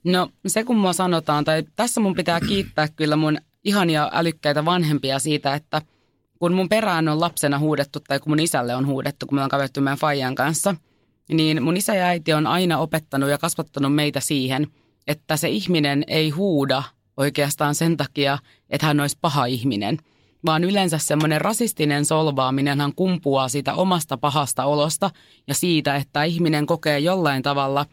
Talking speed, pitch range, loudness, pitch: 170 wpm, 140-170 Hz, -21 LUFS, 150 Hz